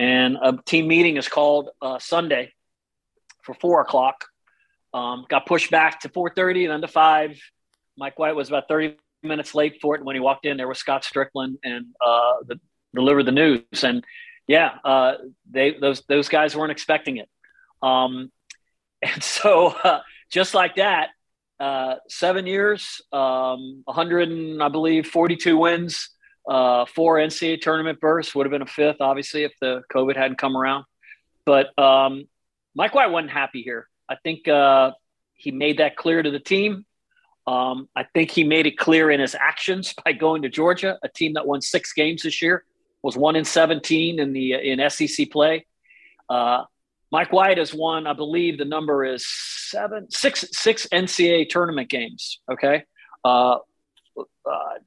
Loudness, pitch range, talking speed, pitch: -21 LUFS, 135-165 Hz, 170 wpm, 150 Hz